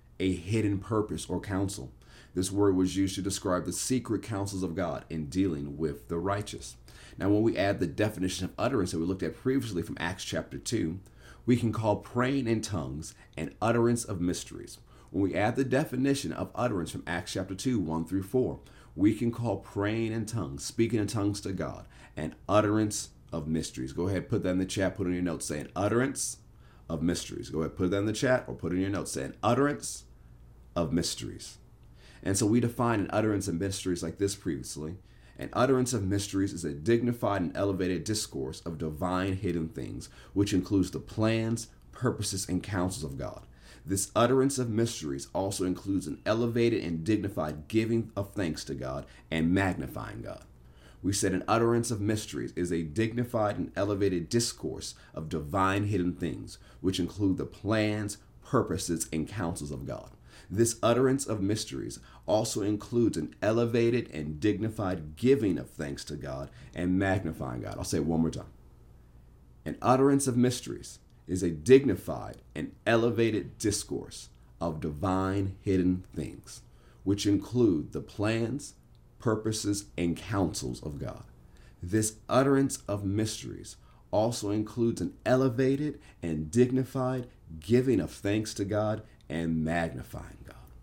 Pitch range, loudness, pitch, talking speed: 85-115 Hz, -30 LUFS, 100 Hz, 165 wpm